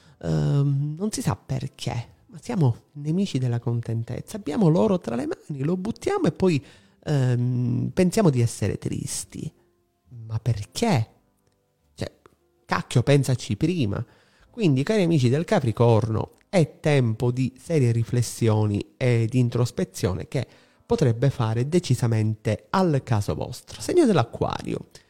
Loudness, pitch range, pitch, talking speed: -24 LUFS, 115-155 Hz, 125 Hz, 125 wpm